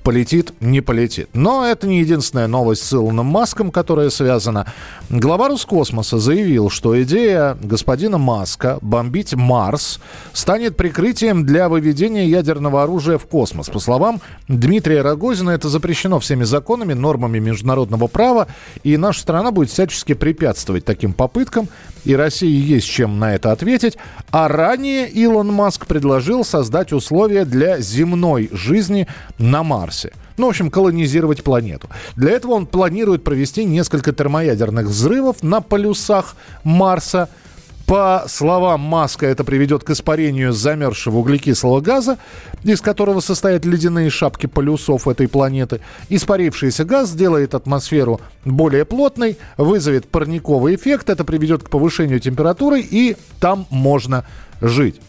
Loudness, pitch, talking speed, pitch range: -16 LUFS, 155 Hz, 130 wpm, 130-190 Hz